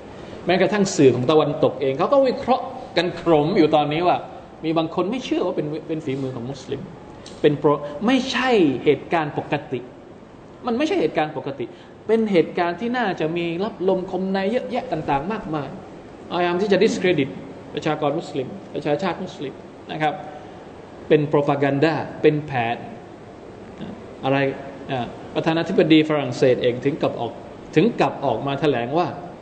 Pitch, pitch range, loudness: 160 Hz, 145-185 Hz, -21 LUFS